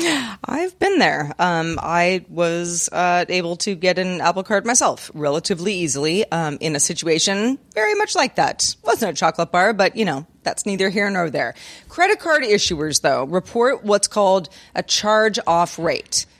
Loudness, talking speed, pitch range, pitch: -19 LUFS, 170 wpm, 165-220 Hz, 185 Hz